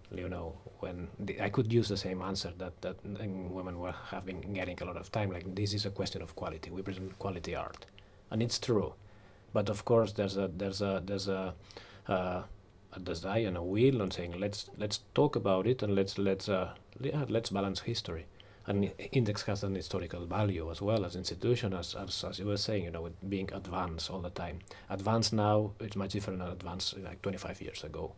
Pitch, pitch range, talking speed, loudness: 95 Hz, 95-105 Hz, 210 wpm, -35 LUFS